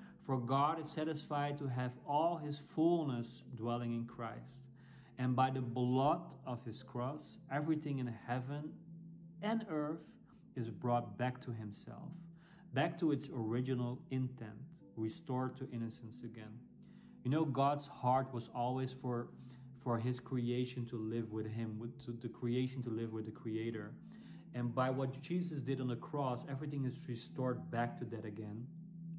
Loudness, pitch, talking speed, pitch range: -40 LUFS, 130 Hz, 155 wpm, 120-150 Hz